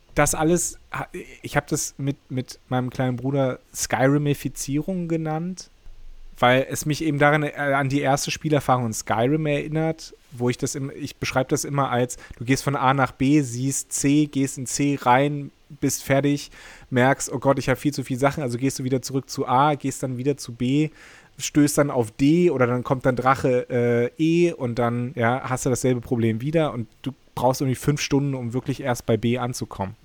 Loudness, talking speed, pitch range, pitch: -23 LUFS, 200 wpm, 125-145 Hz, 135 Hz